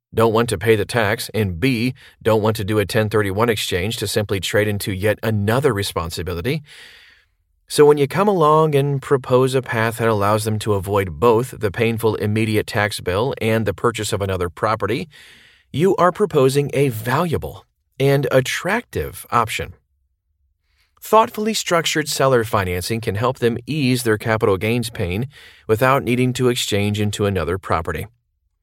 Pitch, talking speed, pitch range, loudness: 110 Hz, 155 wpm, 100-130 Hz, -19 LUFS